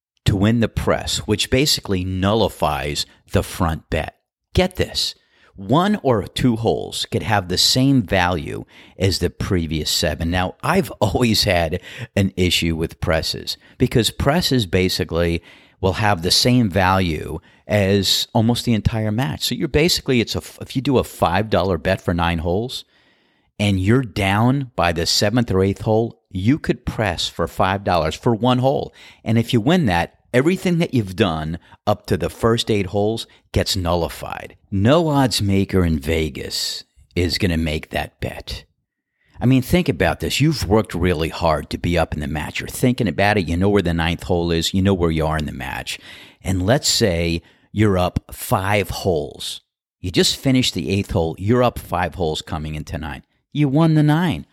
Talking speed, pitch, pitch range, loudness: 180 wpm, 100 Hz, 85-115 Hz, -19 LUFS